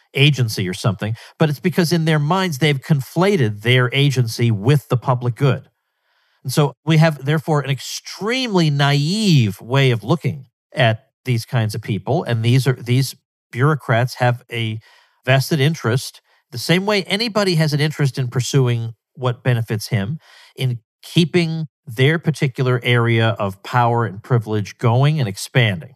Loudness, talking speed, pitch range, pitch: -18 LUFS, 155 wpm, 120-155 Hz, 130 Hz